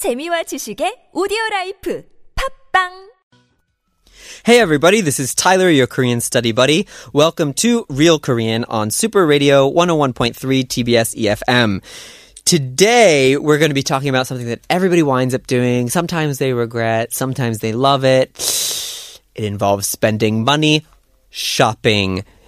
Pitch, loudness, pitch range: 140 Hz, -15 LUFS, 120-200 Hz